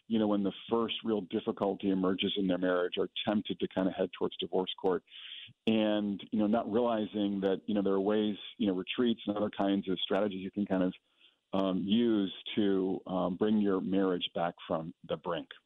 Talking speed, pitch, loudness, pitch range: 205 wpm, 100 Hz, -32 LUFS, 95-105 Hz